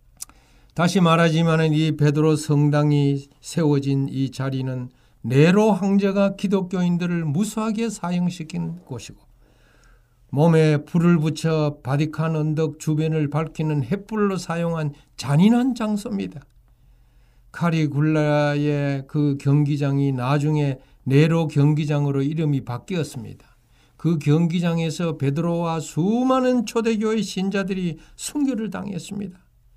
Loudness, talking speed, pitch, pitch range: -21 LUFS, 265 characters per minute, 155 Hz, 140-175 Hz